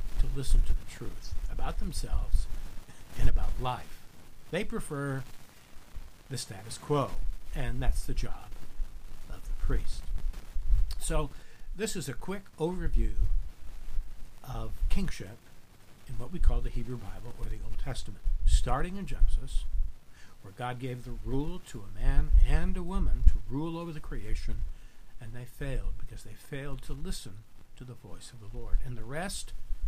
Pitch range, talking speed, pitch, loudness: 95-140 Hz, 155 wpm, 120 Hz, -36 LUFS